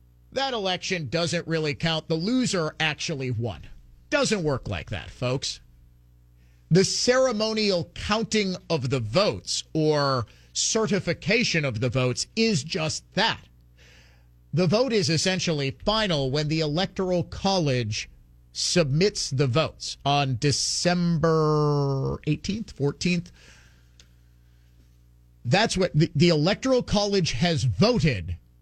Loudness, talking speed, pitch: -24 LUFS, 110 wpm, 150 Hz